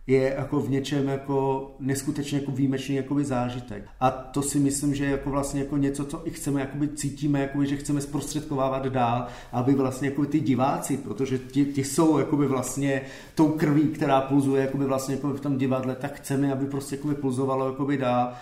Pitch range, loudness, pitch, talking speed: 135-145 Hz, -26 LUFS, 140 Hz, 180 wpm